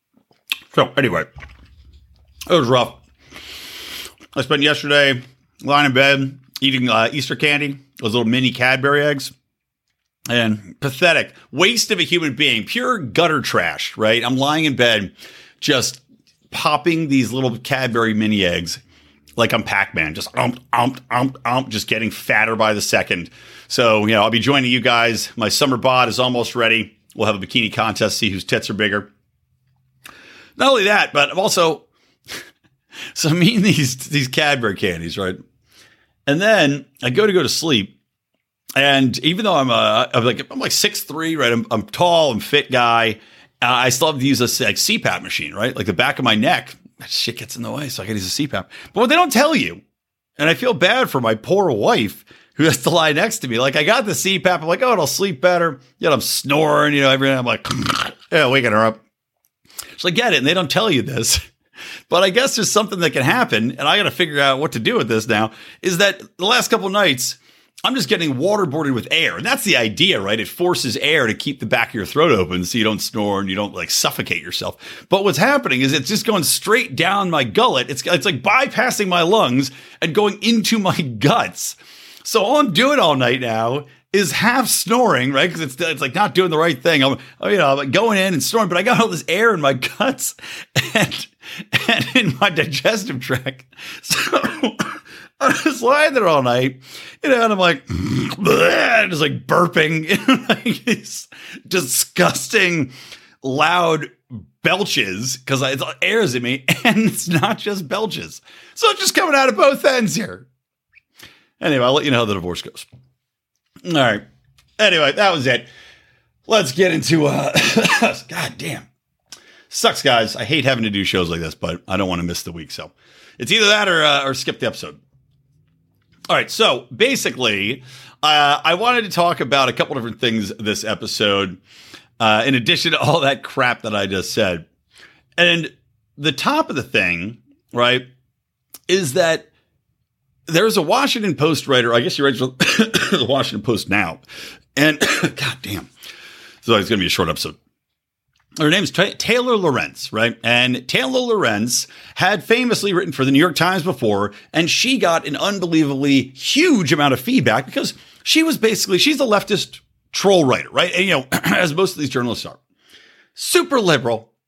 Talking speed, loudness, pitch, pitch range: 190 wpm, -17 LUFS, 135 Hz, 120-180 Hz